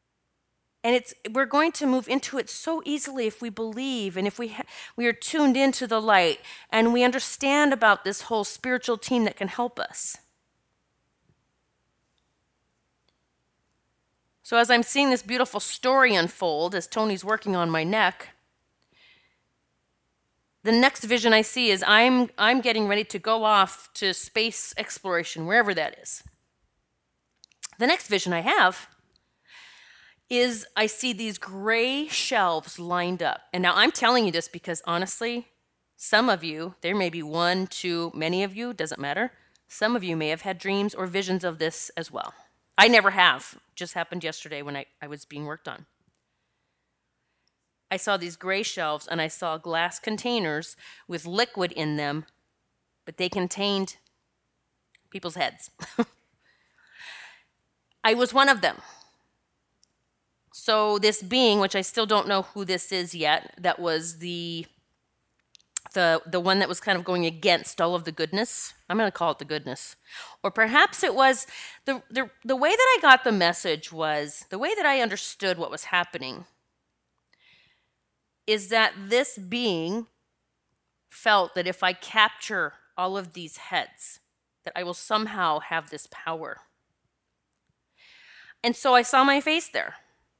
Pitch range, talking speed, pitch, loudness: 170-235 Hz, 155 wpm, 200 Hz, -24 LUFS